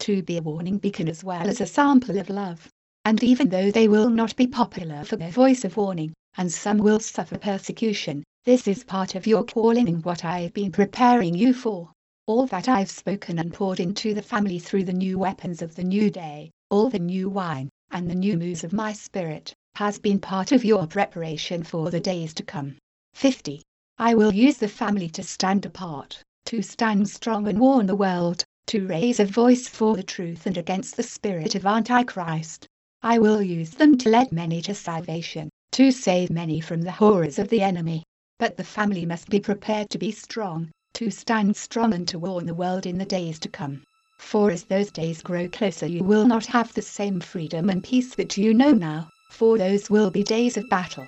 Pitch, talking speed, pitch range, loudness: 200 Hz, 210 wpm, 175-220 Hz, -23 LUFS